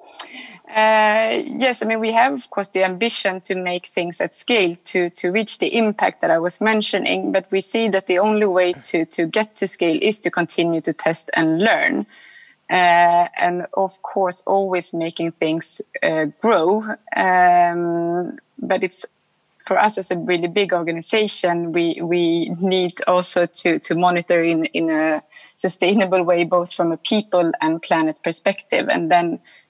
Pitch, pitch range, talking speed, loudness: 180 Hz, 170-200 Hz, 170 wpm, -19 LUFS